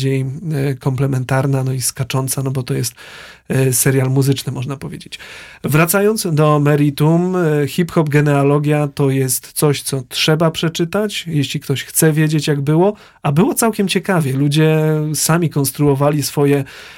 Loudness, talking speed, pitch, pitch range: -16 LUFS, 135 wpm, 145 Hz, 135-160 Hz